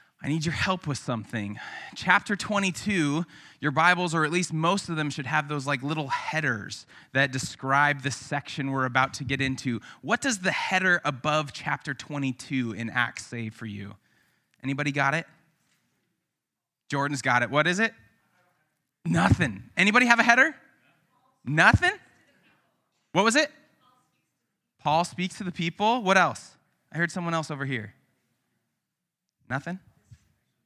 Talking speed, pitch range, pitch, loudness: 145 wpm, 130-180 Hz, 150 Hz, -25 LUFS